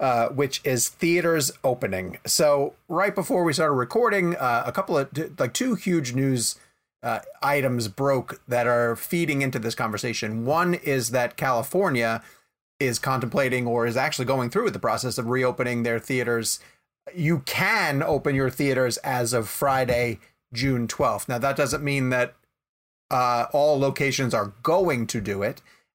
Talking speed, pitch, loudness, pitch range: 160 wpm, 130 Hz, -24 LUFS, 120-145 Hz